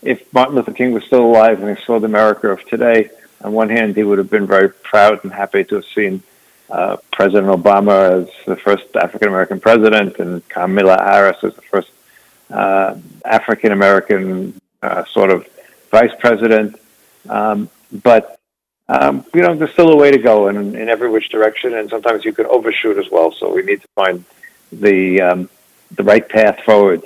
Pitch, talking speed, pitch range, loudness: 105 Hz, 190 wpm, 95-115 Hz, -13 LUFS